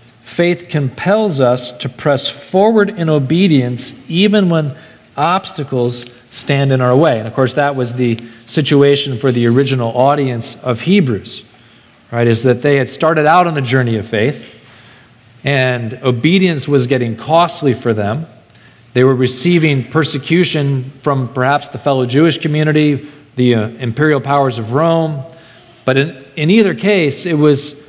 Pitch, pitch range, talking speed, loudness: 140 Hz, 125-155 Hz, 150 wpm, -14 LUFS